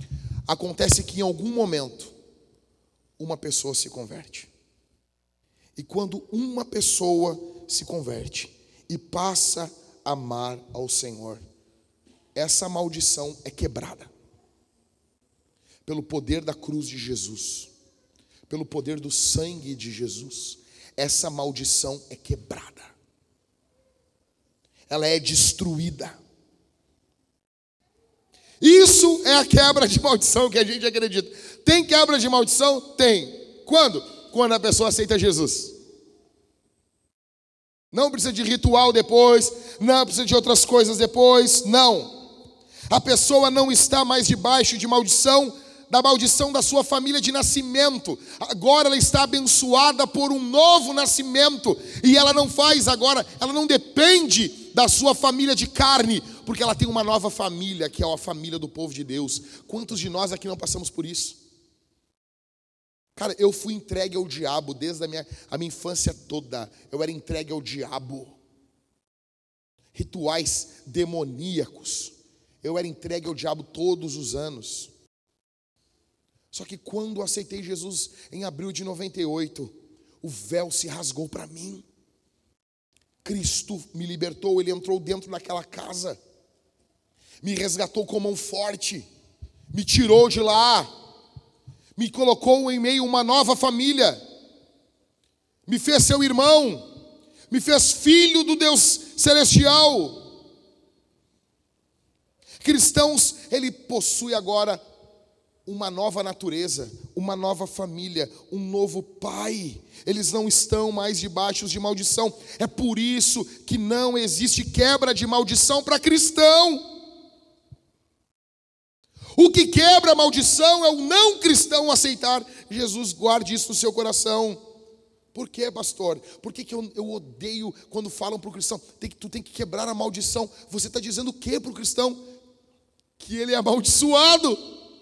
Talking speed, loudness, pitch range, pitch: 130 wpm, -20 LUFS, 165-255 Hz, 215 Hz